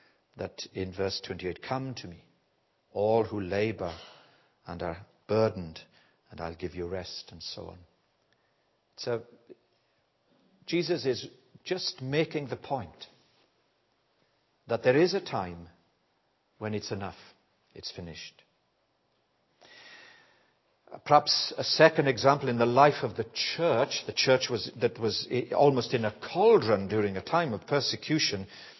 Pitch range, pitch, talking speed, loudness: 95-145 Hz, 115 Hz, 130 wpm, -28 LUFS